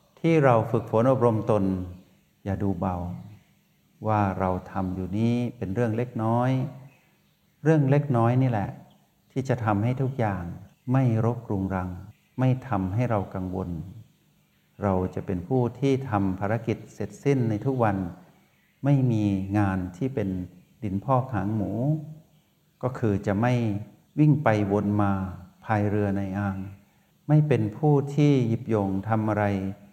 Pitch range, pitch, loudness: 100-130 Hz, 110 Hz, -26 LUFS